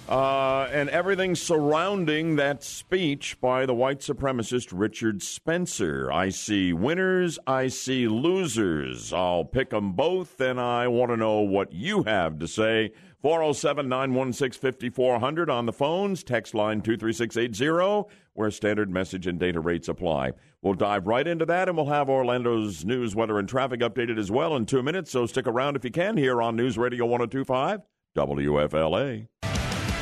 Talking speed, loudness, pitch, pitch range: 160 wpm, -26 LUFS, 125 Hz, 110-145 Hz